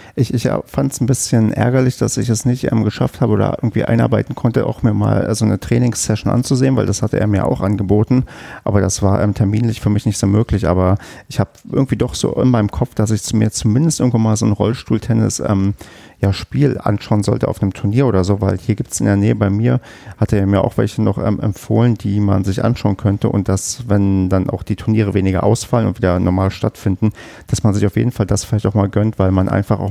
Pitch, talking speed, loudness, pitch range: 110 Hz, 240 wpm, -16 LUFS, 100-120 Hz